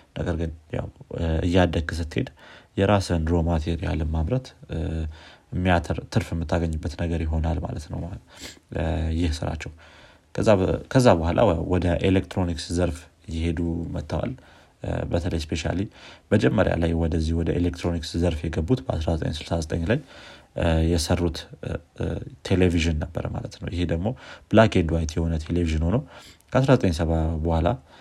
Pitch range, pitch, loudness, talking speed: 80-95 Hz, 85 Hz, -25 LUFS, 105 wpm